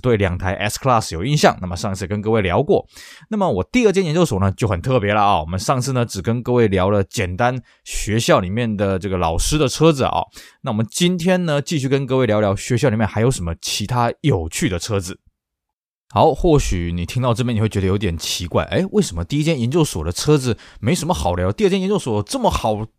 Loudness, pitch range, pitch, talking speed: -19 LUFS, 95-140 Hz, 110 Hz, 350 characters per minute